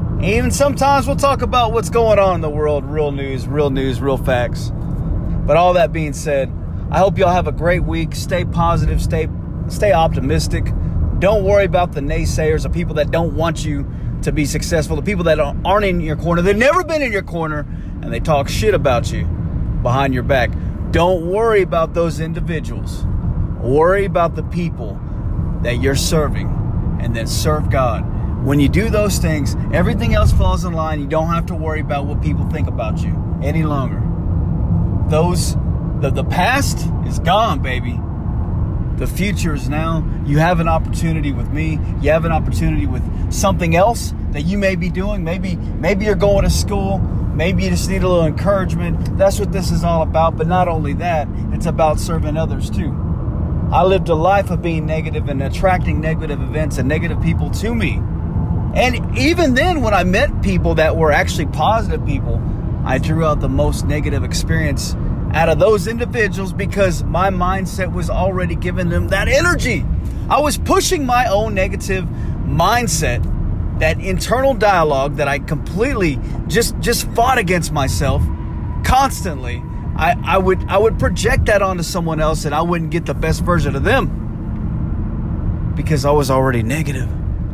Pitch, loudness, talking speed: 140 Hz, -17 LUFS, 175 wpm